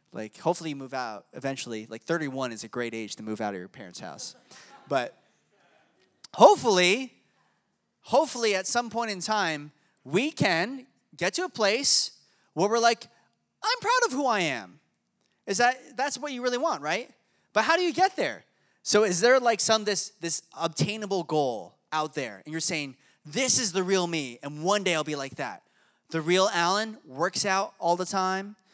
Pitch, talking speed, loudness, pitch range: 190 Hz, 190 wpm, -26 LUFS, 150-235 Hz